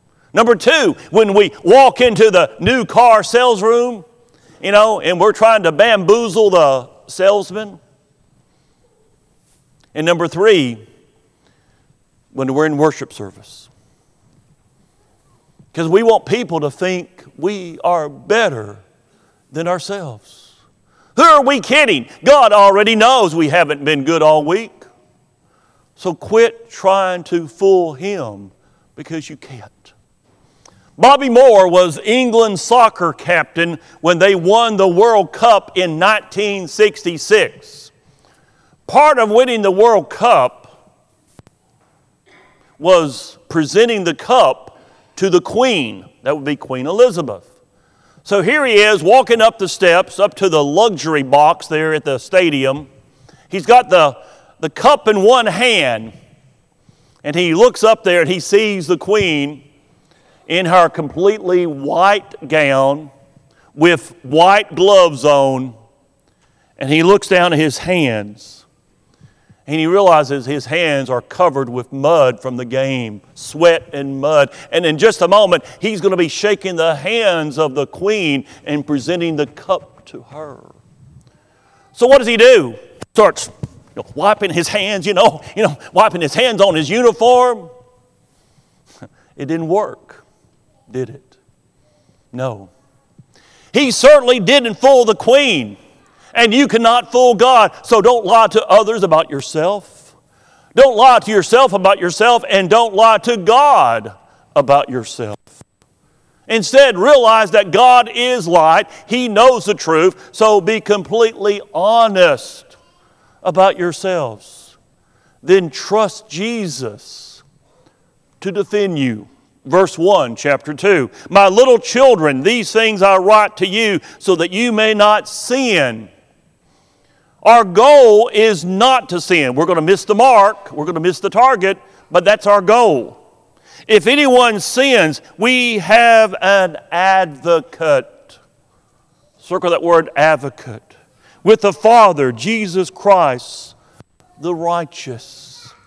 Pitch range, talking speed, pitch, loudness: 150-220 Hz, 130 wpm, 185 Hz, -12 LUFS